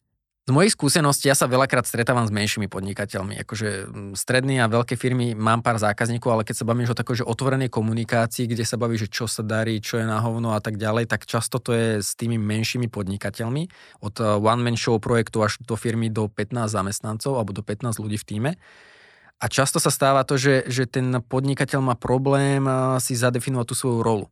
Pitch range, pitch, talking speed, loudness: 110-130 Hz, 120 Hz, 200 wpm, -23 LUFS